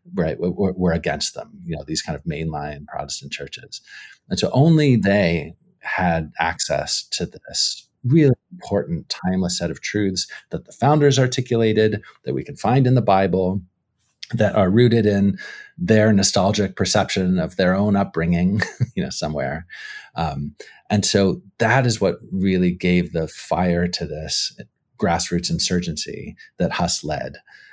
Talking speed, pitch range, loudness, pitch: 150 wpm, 85-110 Hz, -20 LUFS, 95 Hz